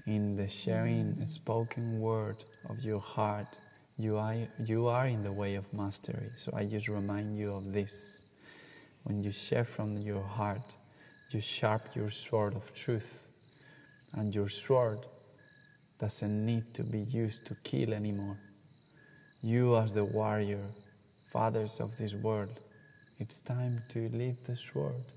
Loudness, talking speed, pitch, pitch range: -35 LUFS, 145 wpm, 110 Hz, 105-125 Hz